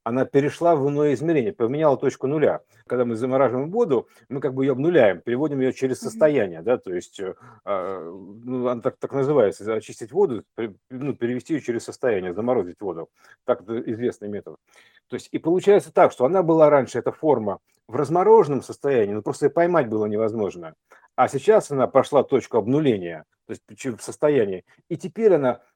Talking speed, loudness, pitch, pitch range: 175 wpm, -22 LUFS, 135 Hz, 125-170 Hz